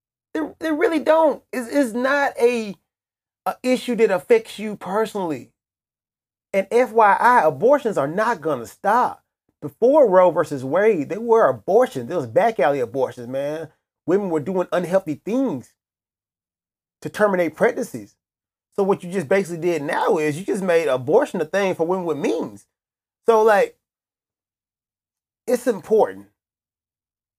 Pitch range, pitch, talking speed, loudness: 150-235 Hz, 190 Hz, 140 wpm, -20 LUFS